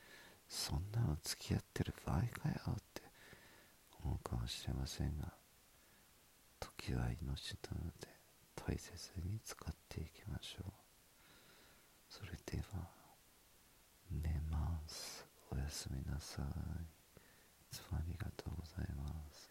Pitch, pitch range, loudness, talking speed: 80 Hz, 70-90 Hz, -46 LUFS, 220 characters per minute